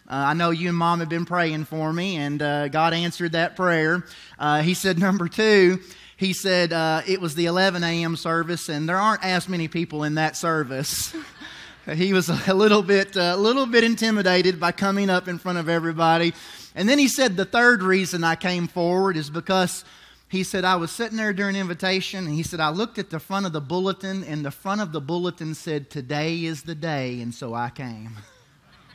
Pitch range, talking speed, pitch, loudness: 160-190 Hz, 210 wpm, 175 Hz, -22 LUFS